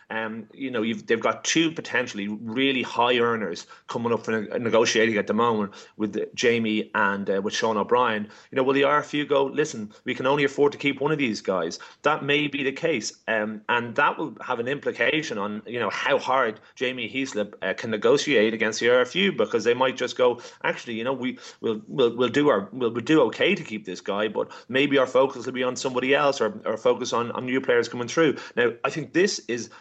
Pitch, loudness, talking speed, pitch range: 125 Hz, -24 LUFS, 225 wpm, 110-145 Hz